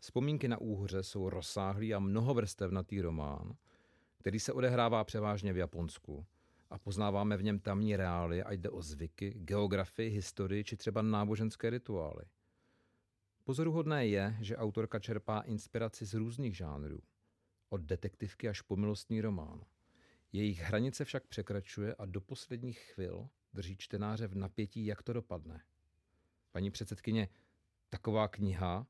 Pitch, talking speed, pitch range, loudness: 105 Hz, 135 wpm, 95-110 Hz, -38 LUFS